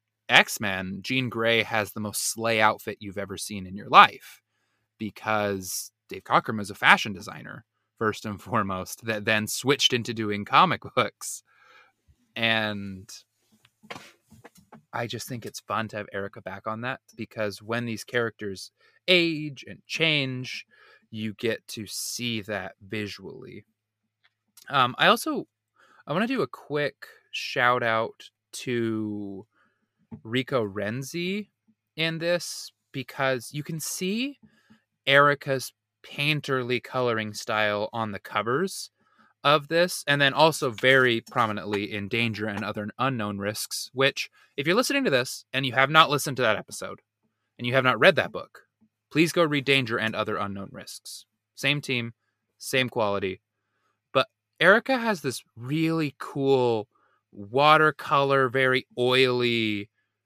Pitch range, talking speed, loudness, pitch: 105-135 Hz, 135 wpm, -25 LUFS, 115 Hz